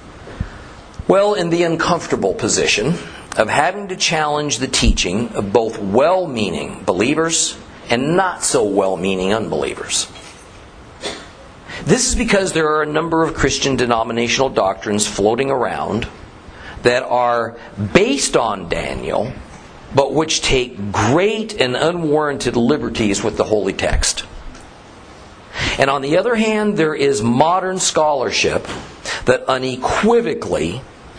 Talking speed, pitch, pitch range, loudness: 120 wpm, 140 Hz, 115-165 Hz, -17 LUFS